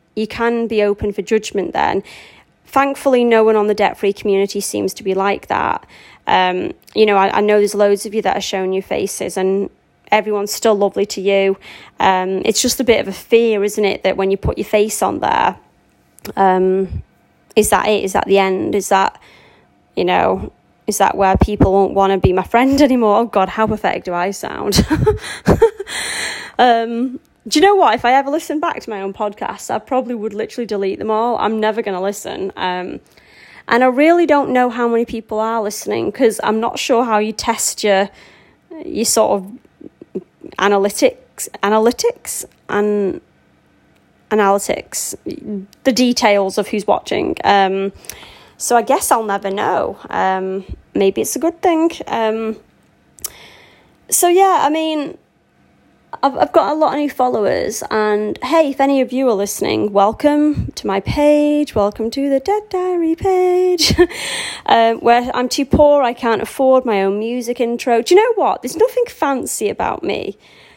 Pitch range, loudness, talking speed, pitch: 200-275 Hz, -16 LUFS, 175 wpm, 220 Hz